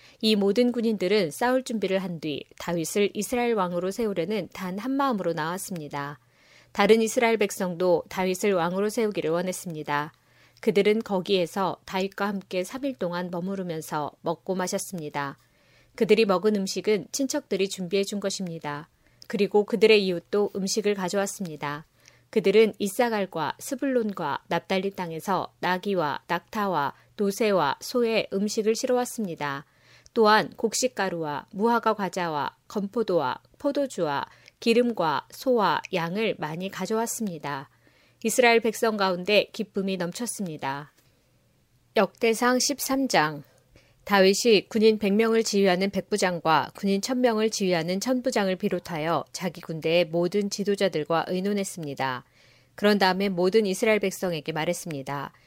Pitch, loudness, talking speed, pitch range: 195 Hz, -26 LUFS, 315 characters per minute, 175-220 Hz